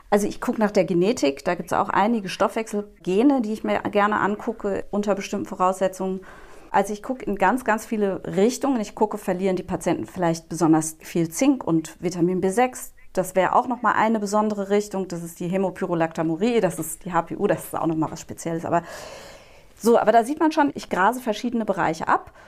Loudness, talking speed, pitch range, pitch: -23 LUFS, 200 wpm, 175-215 Hz, 195 Hz